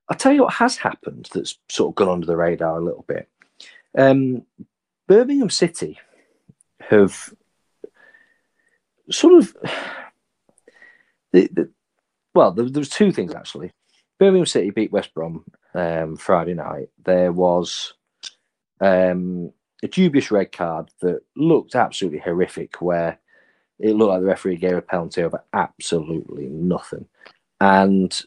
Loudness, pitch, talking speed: -19 LUFS, 100 Hz, 130 wpm